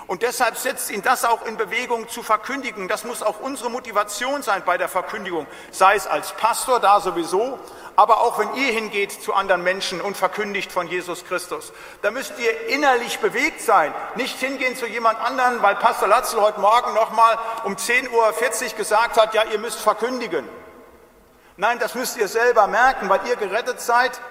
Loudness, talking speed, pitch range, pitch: -20 LUFS, 185 wpm, 200-245 Hz, 225 Hz